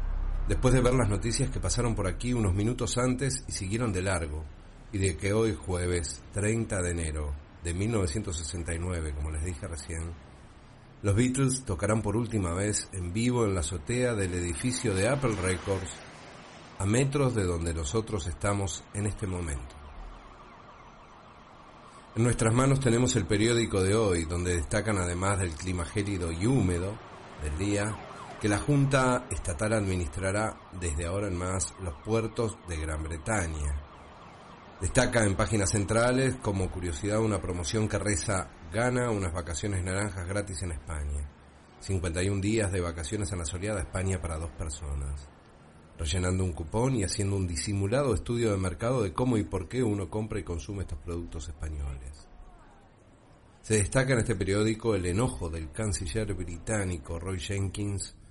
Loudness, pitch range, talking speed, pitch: -30 LUFS, 85-110 Hz, 155 wpm, 95 Hz